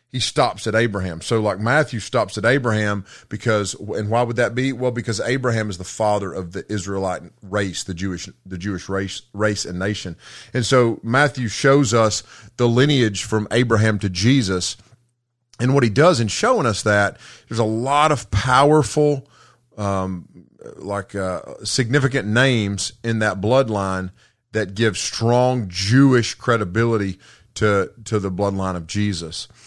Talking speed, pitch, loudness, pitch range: 155 wpm, 110 Hz, -20 LUFS, 100-120 Hz